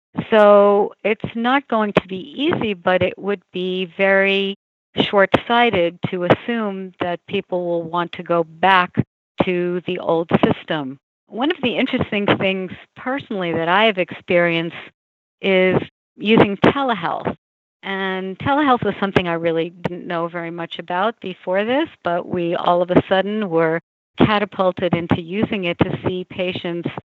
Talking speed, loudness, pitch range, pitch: 150 wpm, -19 LUFS, 175-205 Hz, 185 Hz